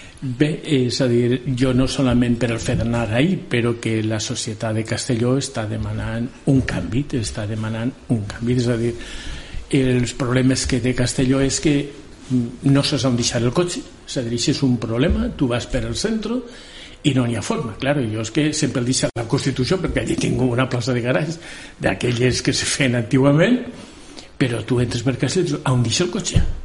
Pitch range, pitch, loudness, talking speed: 120-140 Hz, 130 Hz, -20 LUFS, 205 wpm